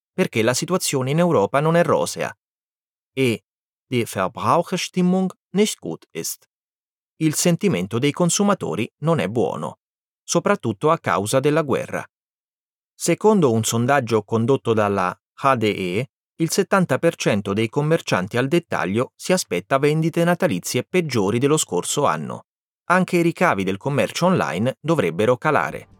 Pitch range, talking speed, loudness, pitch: 115-175 Hz, 125 wpm, -20 LUFS, 150 Hz